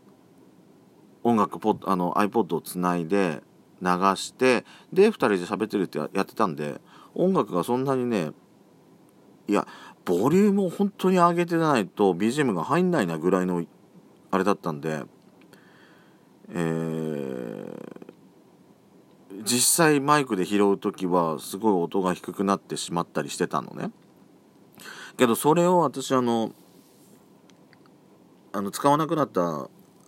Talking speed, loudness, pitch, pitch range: 245 characters per minute, -24 LUFS, 100 Hz, 90-140 Hz